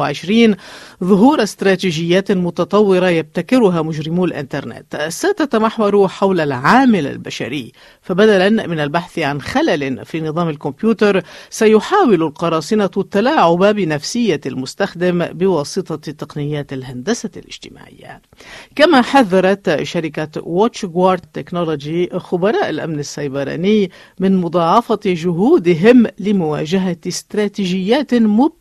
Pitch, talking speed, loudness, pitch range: 185 Hz, 85 wpm, -15 LUFS, 160-210 Hz